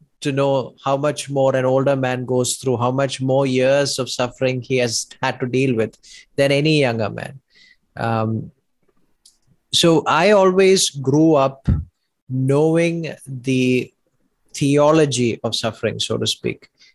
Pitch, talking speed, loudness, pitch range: 135 Hz, 140 wpm, -18 LUFS, 125-145 Hz